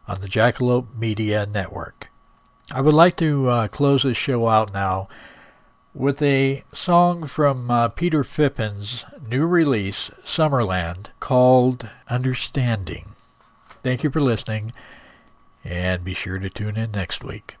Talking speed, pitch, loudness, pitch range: 135 wpm, 120 Hz, -21 LUFS, 105-140 Hz